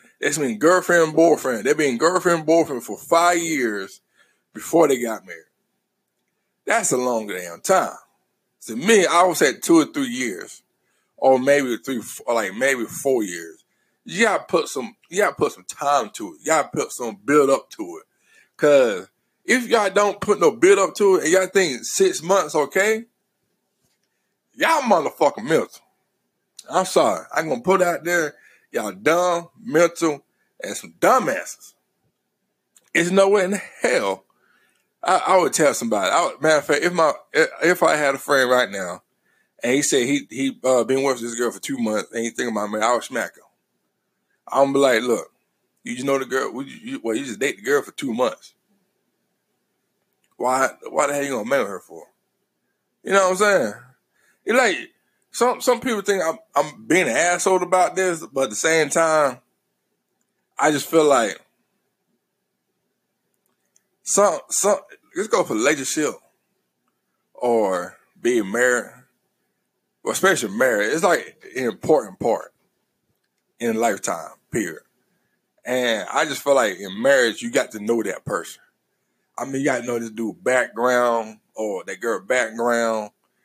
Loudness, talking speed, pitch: -20 LUFS, 170 wpm, 175 Hz